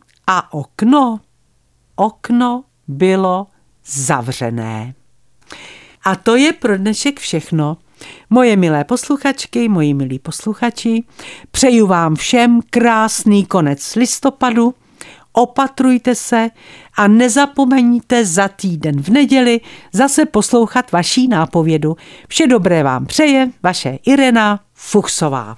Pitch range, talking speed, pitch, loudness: 165-250 Hz, 100 wpm, 215 Hz, -14 LUFS